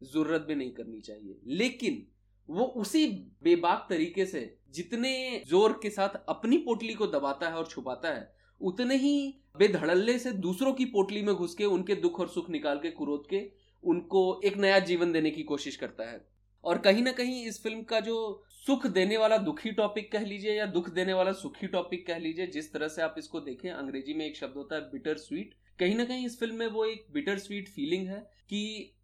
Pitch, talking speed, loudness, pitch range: 195 Hz, 205 wpm, -31 LUFS, 155-225 Hz